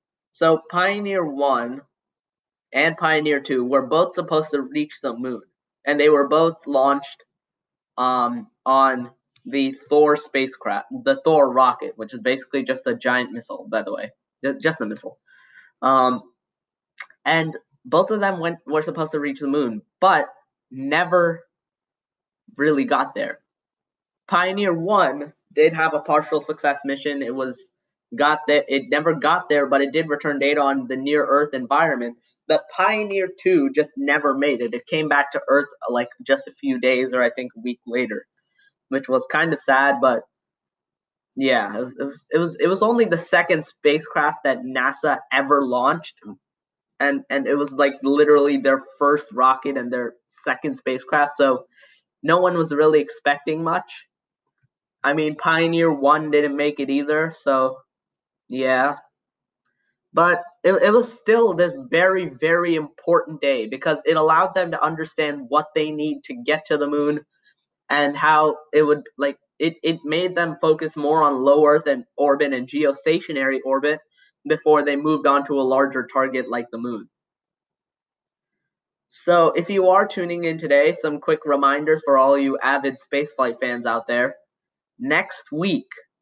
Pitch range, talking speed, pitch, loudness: 135-160 Hz, 160 wpm, 150 Hz, -20 LUFS